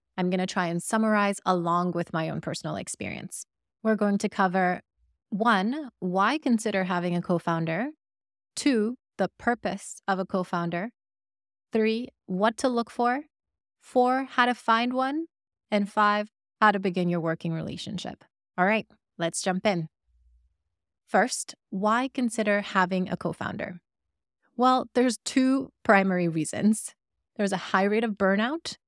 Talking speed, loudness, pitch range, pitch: 145 wpm, -27 LUFS, 180-235 Hz, 205 Hz